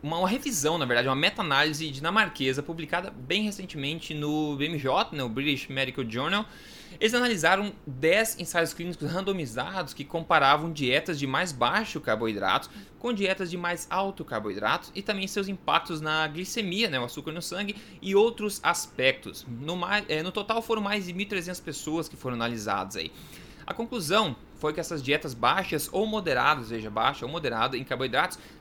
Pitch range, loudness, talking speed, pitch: 140-195 Hz, -28 LUFS, 165 wpm, 165 Hz